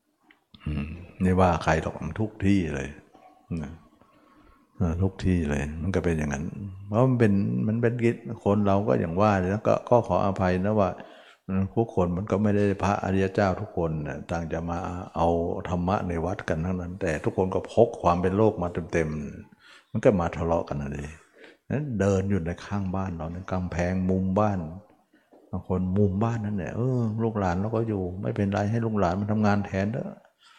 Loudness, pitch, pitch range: -26 LUFS, 95 Hz, 85-105 Hz